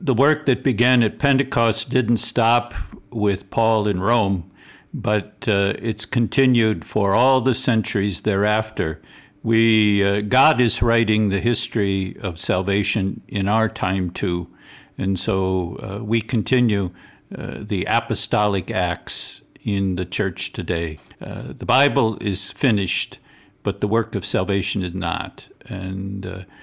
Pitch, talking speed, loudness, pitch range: 105 Hz, 135 wpm, -20 LUFS, 95-115 Hz